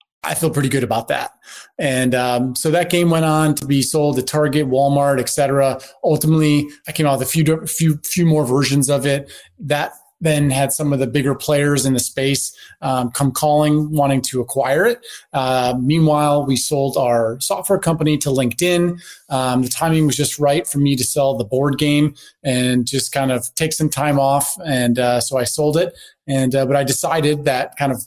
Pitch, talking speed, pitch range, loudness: 140 Hz, 205 wpm, 135-155 Hz, -17 LUFS